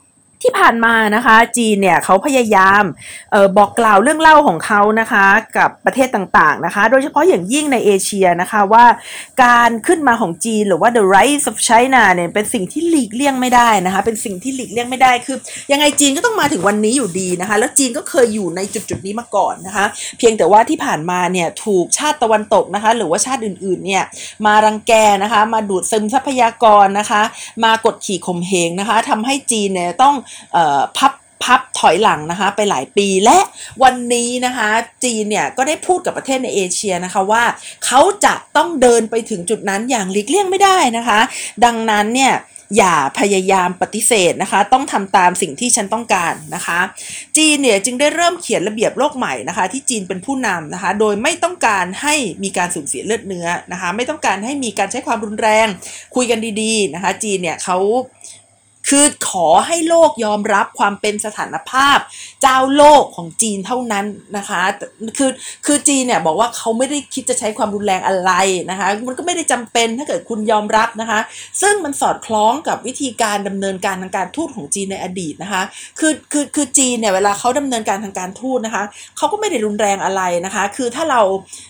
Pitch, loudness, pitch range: 225 Hz, -14 LUFS, 195-260 Hz